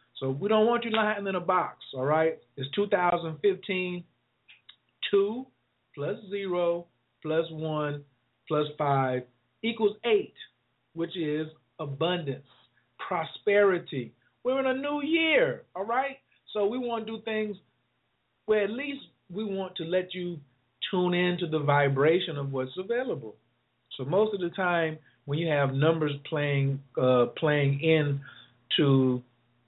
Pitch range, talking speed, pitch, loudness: 140-205 Hz, 140 wpm, 165 Hz, -28 LUFS